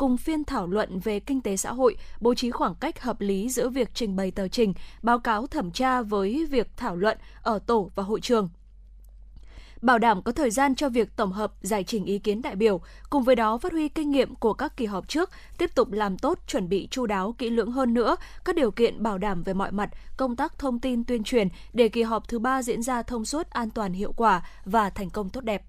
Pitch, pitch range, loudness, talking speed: 230 Hz, 205-260 Hz, -26 LUFS, 245 wpm